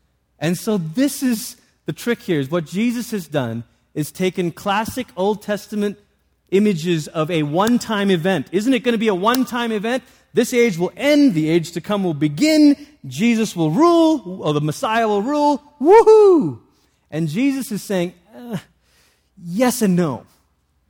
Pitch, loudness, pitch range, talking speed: 205 Hz, -18 LUFS, 170-245 Hz, 165 wpm